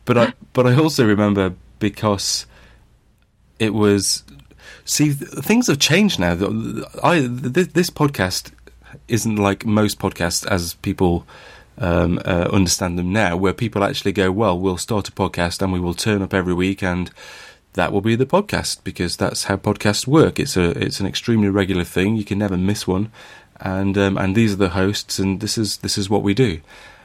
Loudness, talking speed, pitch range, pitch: -19 LUFS, 185 wpm, 95-110 Hz, 100 Hz